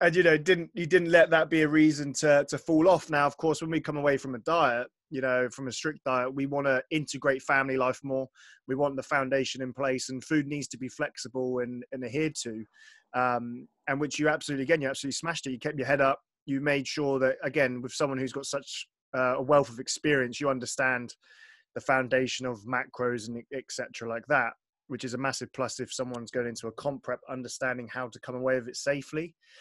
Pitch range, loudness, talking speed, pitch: 125-150 Hz, -29 LUFS, 230 wpm, 135 Hz